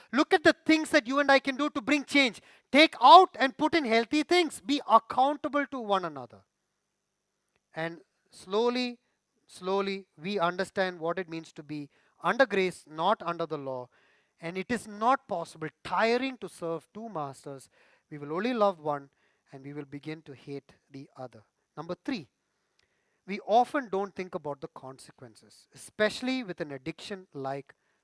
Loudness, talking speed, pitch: -27 LUFS, 165 wpm, 190 Hz